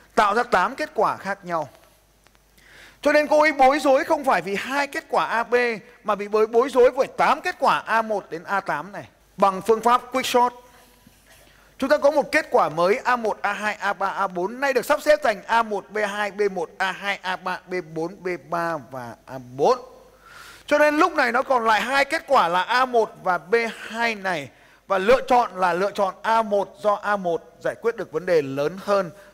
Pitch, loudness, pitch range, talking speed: 220 Hz, -22 LUFS, 195-265 Hz, 190 wpm